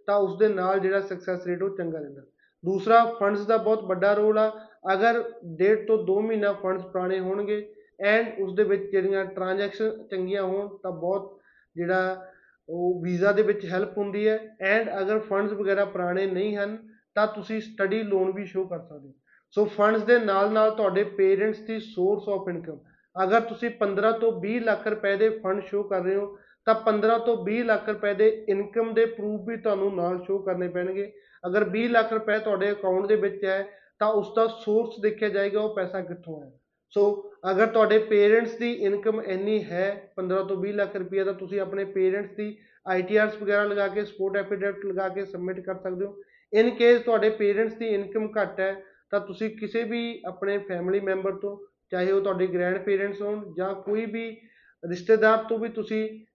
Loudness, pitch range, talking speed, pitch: -26 LUFS, 190-215 Hz, 185 wpm, 200 Hz